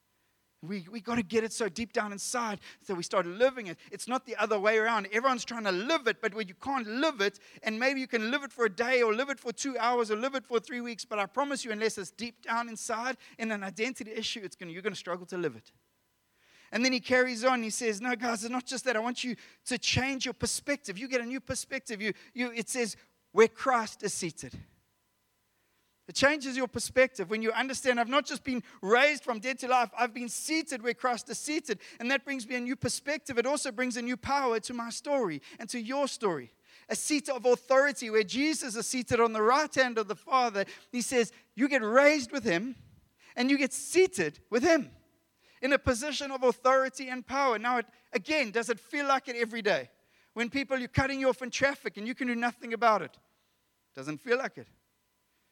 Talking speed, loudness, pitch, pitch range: 235 wpm, -30 LUFS, 240 Hz, 215-260 Hz